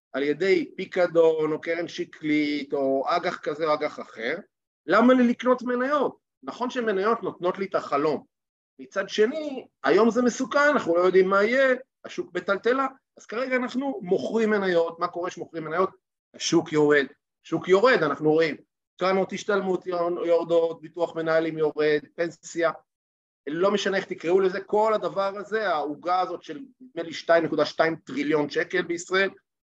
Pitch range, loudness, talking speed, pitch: 160-215 Hz, -24 LUFS, 150 wpm, 180 Hz